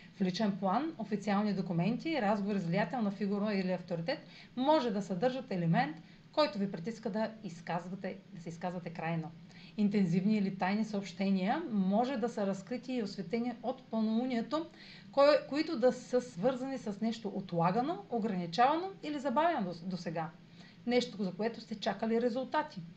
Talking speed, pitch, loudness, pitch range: 140 wpm, 205 Hz, -34 LUFS, 185-245 Hz